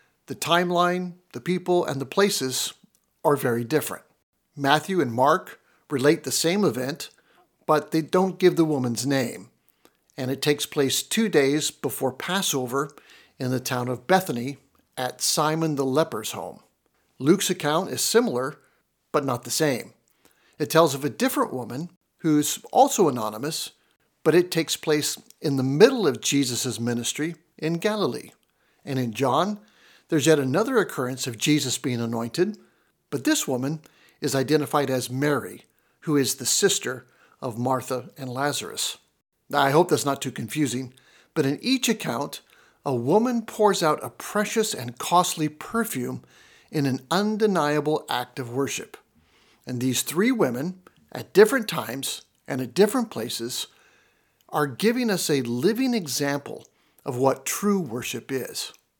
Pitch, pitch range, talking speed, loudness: 150 Hz, 130-180 Hz, 145 wpm, -24 LUFS